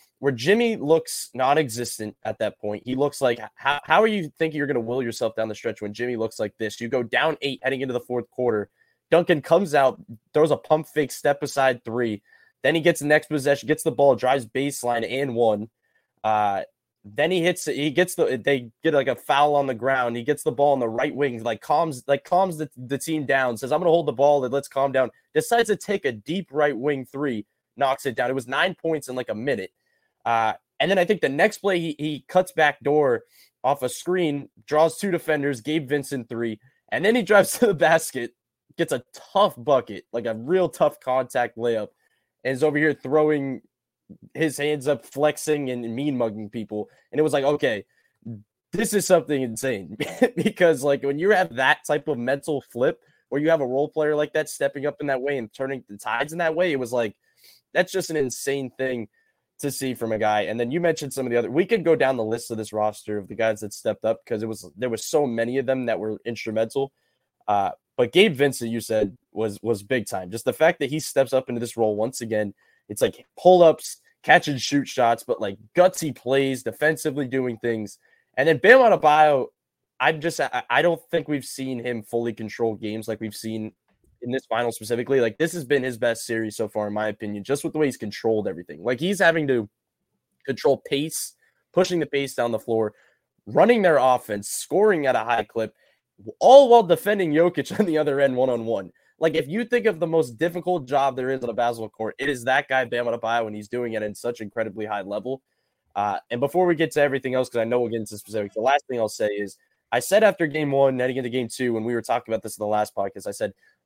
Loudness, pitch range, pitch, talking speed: -23 LUFS, 115-155 Hz, 135 Hz, 235 wpm